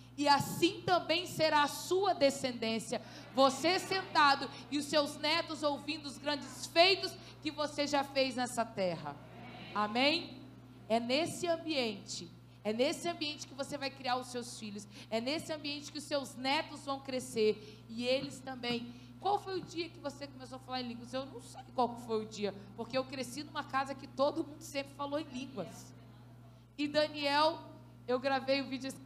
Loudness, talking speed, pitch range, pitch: -35 LUFS, 180 wpm, 240-300 Hz, 275 Hz